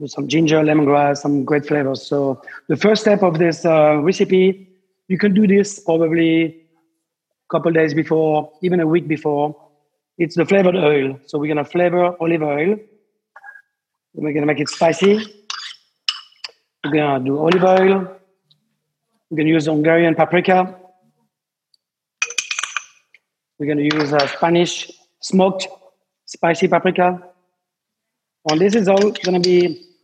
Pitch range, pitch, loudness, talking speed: 150-190 Hz, 170 Hz, -17 LUFS, 135 wpm